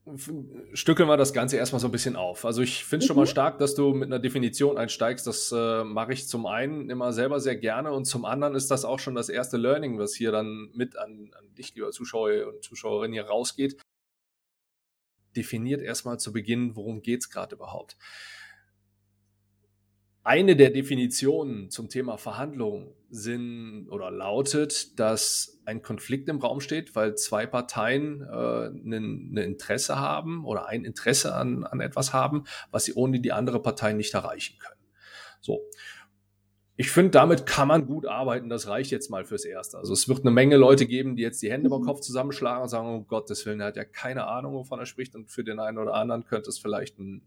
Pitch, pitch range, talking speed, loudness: 125 Hz, 110-140 Hz, 195 wpm, -26 LUFS